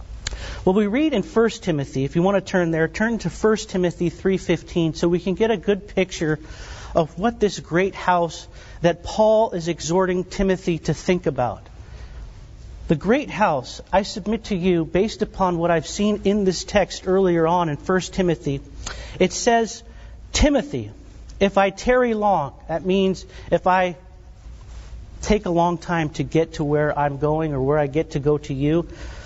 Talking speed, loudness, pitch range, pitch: 175 wpm, -21 LUFS, 160-195 Hz, 180 Hz